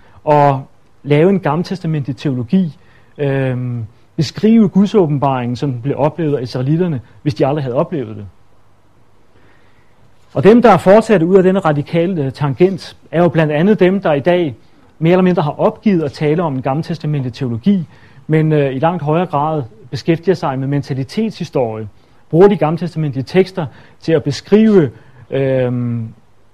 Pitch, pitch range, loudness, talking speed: 145 Hz, 125-175 Hz, -14 LUFS, 150 wpm